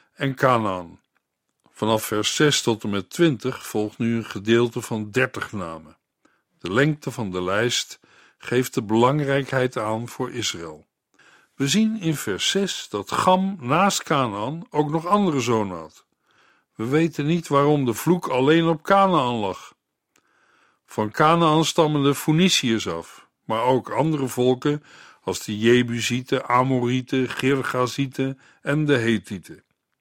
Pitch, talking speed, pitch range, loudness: 130 Hz, 140 wpm, 115-150 Hz, -22 LUFS